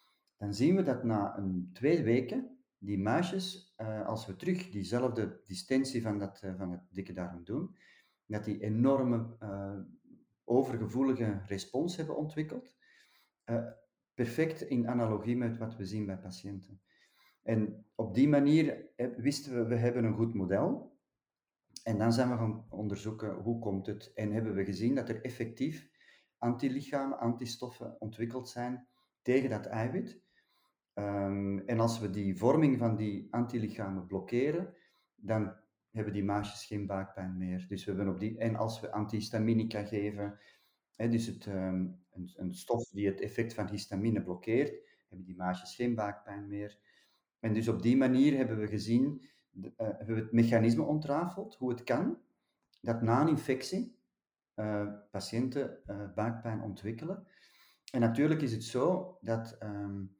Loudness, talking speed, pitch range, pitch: -34 LUFS, 150 wpm, 100-125 Hz, 110 Hz